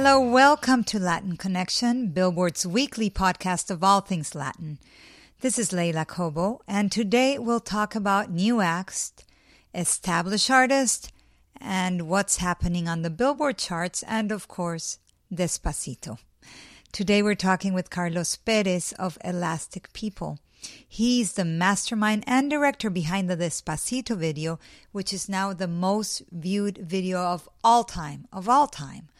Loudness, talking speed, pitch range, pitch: -25 LUFS, 140 wpm, 175-220 Hz, 190 Hz